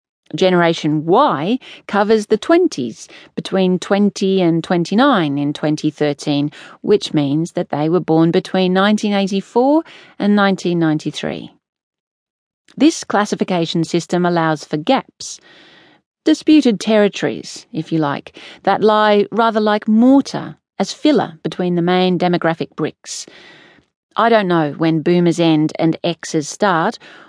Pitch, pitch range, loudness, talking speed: 180 Hz, 160-215 Hz, -16 LUFS, 115 wpm